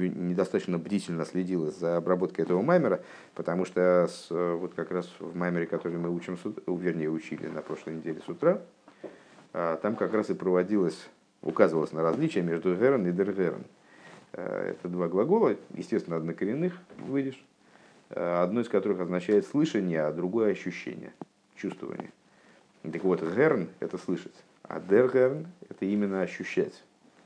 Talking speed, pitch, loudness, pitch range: 135 wpm, 90 Hz, -29 LUFS, 85-100 Hz